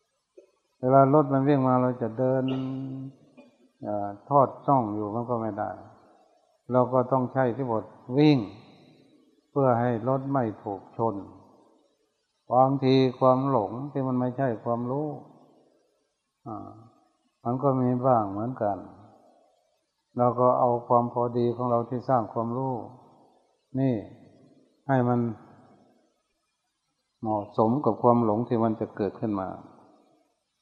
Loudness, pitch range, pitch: -26 LUFS, 115-130 Hz, 125 Hz